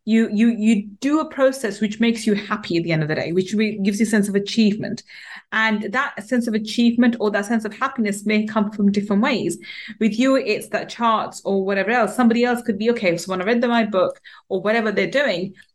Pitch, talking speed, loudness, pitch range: 220 Hz, 235 wpm, -20 LUFS, 205-235 Hz